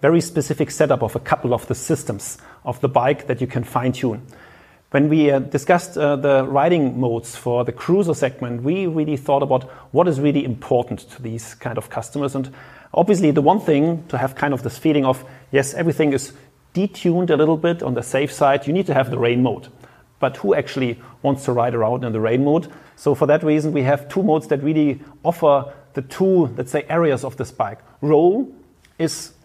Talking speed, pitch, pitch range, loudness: 210 wpm, 140 Hz, 125-155 Hz, -19 LUFS